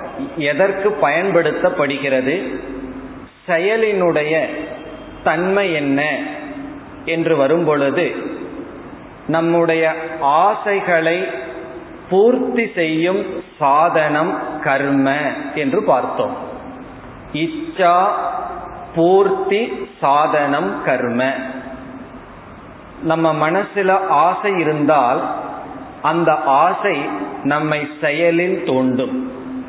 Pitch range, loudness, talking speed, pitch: 140-190 Hz, -17 LUFS, 55 wpm, 160 Hz